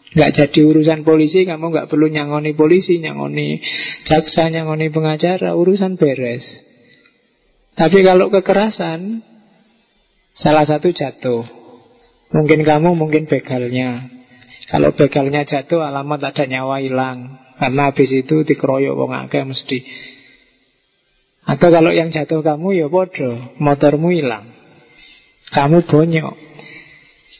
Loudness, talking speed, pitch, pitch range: -15 LUFS, 110 wpm, 155 Hz, 130-165 Hz